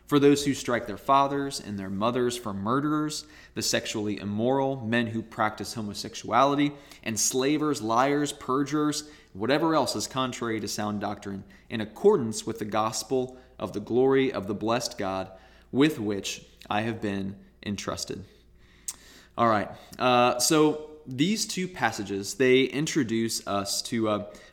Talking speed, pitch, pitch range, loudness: 140 wpm, 115 Hz, 105-140 Hz, -27 LUFS